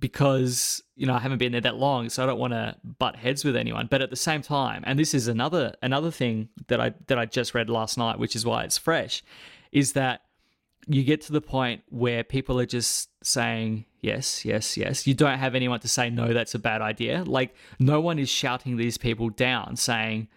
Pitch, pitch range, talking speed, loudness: 125 Hz, 115-135 Hz, 225 wpm, -26 LUFS